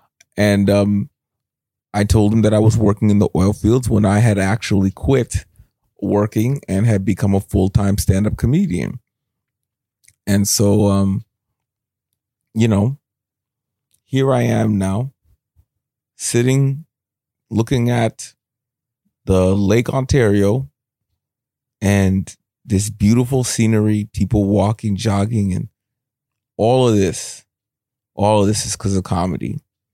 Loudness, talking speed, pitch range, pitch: -17 LUFS, 120 wpm, 100-125 Hz, 110 Hz